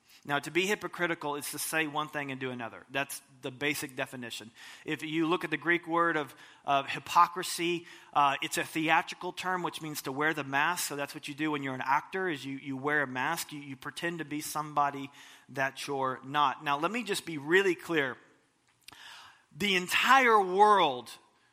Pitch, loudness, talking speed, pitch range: 150 Hz, -30 LUFS, 200 wpm, 140-170 Hz